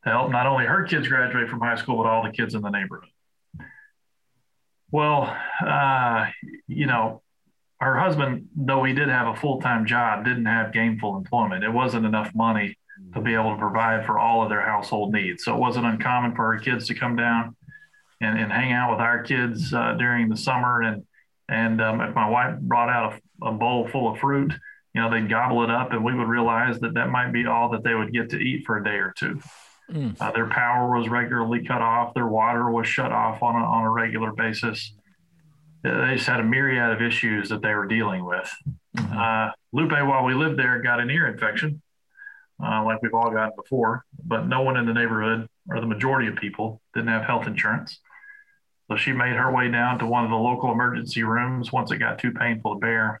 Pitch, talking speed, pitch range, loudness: 120 Hz, 215 wpm, 115-130 Hz, -23 LUFS